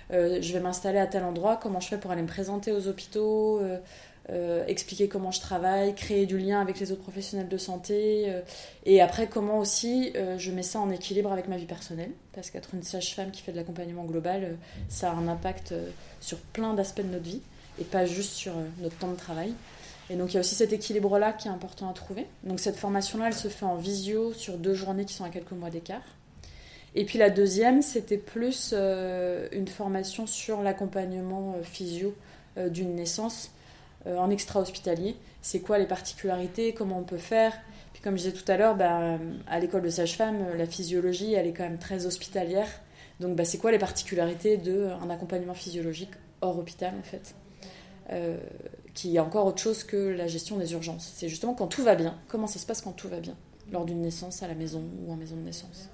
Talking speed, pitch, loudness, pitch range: 215 wpm, 190 Hz, -30 LUFS, 180-205 Hz